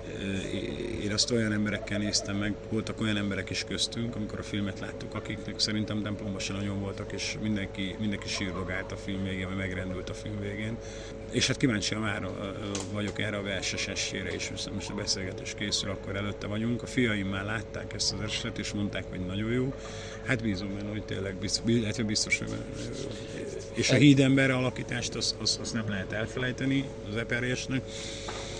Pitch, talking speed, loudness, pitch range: 110 Hz, 175 wpm, -31 LUFS, 100-110 Hz